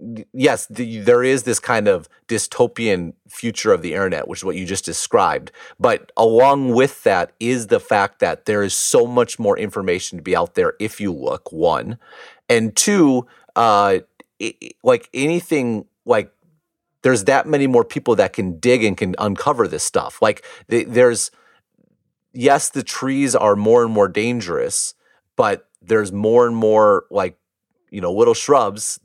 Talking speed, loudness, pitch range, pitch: 165 wpm, -18 LUFS, 110-145 Hz, 120 Hz